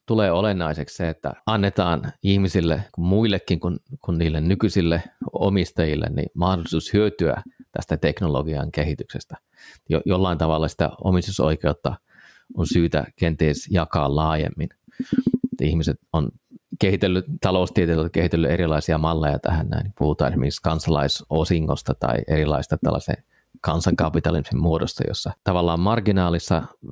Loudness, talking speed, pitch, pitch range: -22 LUFS, 105 wpm, 85 Hz, 80-100 Hz